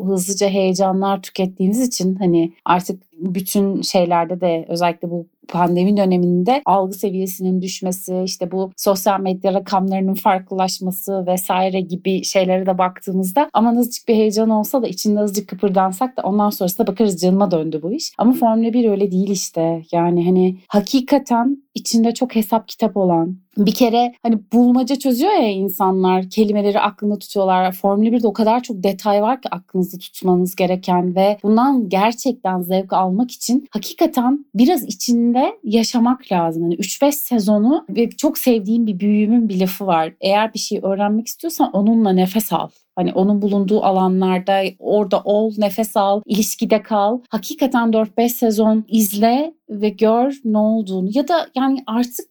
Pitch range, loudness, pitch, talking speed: 185-230 Hz, -17 LUFS, 205 Hz, 155 wpm